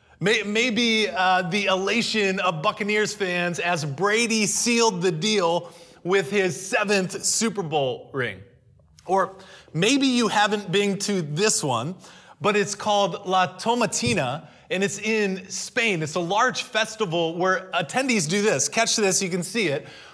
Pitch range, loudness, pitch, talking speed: 180-215 Hz, -22 LUFS, 195 Hz, 145 wpm